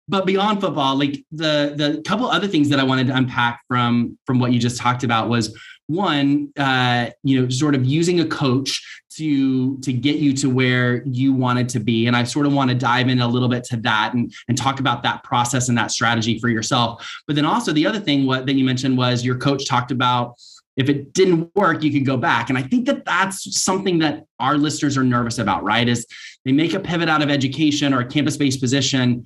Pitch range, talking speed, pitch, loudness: 125-150 Hz, 235 wpm, 135 Hz, -19 LUFS